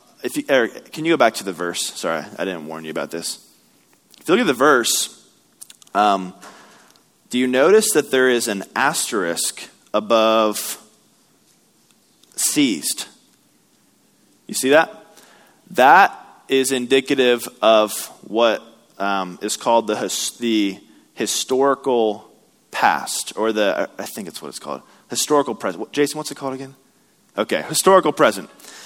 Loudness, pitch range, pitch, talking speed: -19 LUFS, 100-135 Hz, 120 Hz, 140 wpm